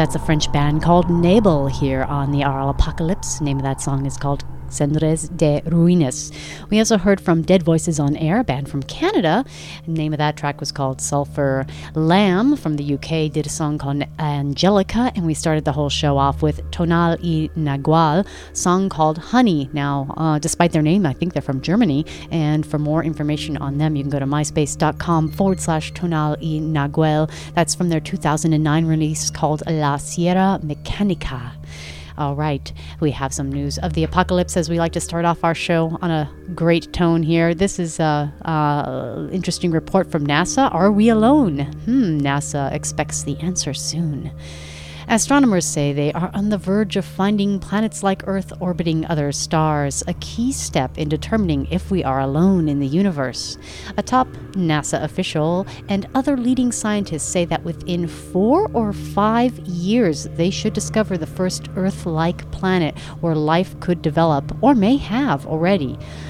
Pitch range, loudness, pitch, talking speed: 145-180 Hz, -19 LUFS, 160 Hz, 175 wpm